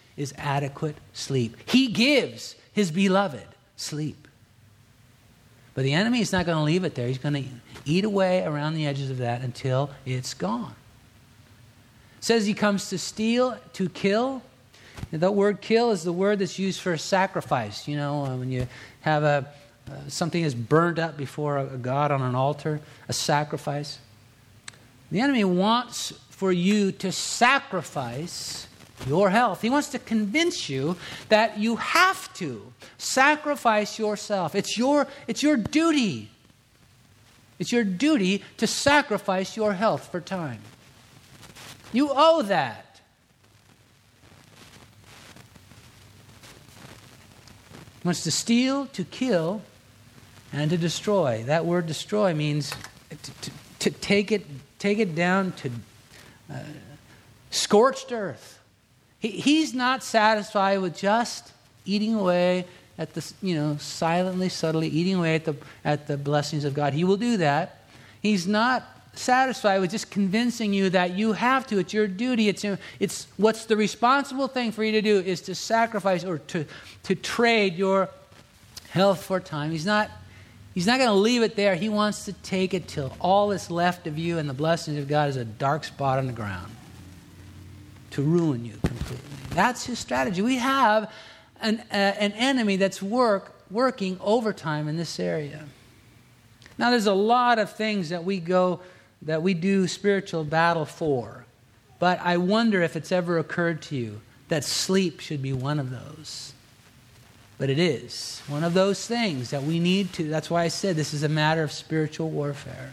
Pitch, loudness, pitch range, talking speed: 165 Hz, -25 LUFS, 130-205 Hz, 160 wpm